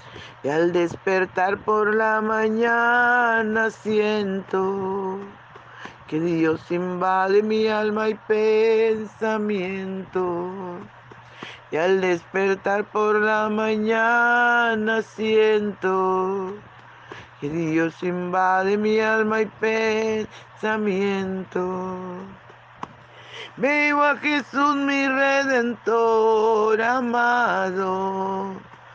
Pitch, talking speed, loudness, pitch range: 210 Hz, 70 wpm, -21 LUFS, 190-220 Hz